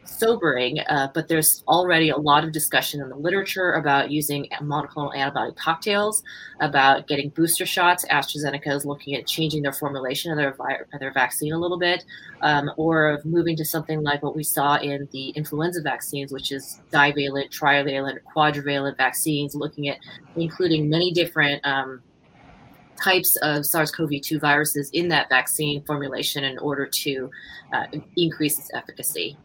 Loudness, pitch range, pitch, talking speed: -22 LUFS, 140-160 Hz, 150 Hz, 165 wpm